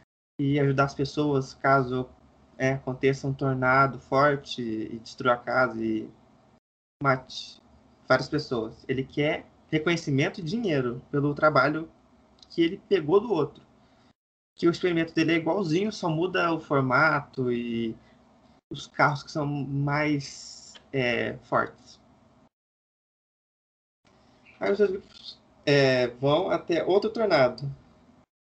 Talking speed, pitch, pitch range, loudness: 120 wpm, 140 Hz, 130-155 Hz, -26 LUFS